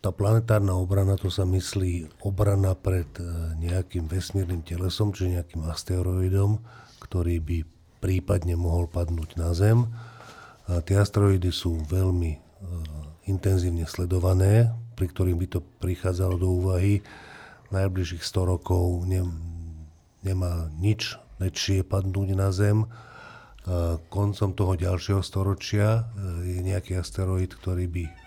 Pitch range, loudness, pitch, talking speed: 85-100 Hz, -26 LUFS, 95 Hz, 110 wpm